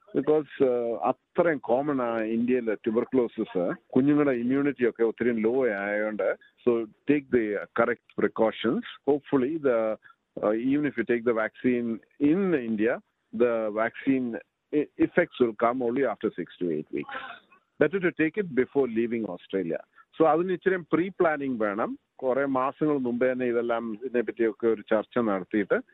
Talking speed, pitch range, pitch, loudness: 135 wpm, 115-145 Hz, 125 Hz, -27 LUFS